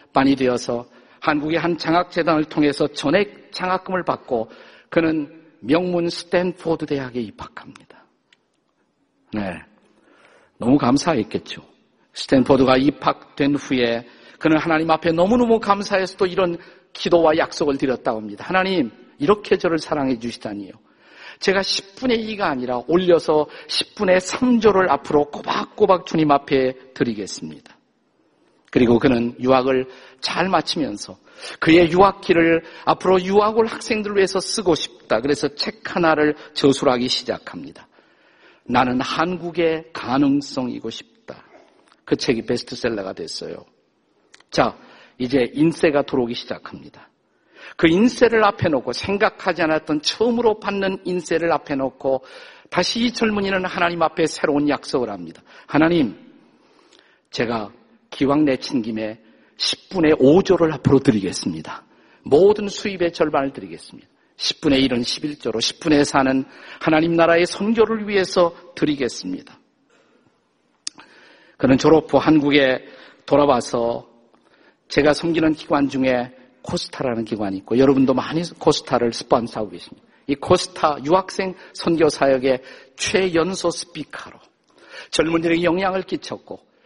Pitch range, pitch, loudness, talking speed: 135-185 Hz, 160 Hz, -19 LUFS, 290 characters per minute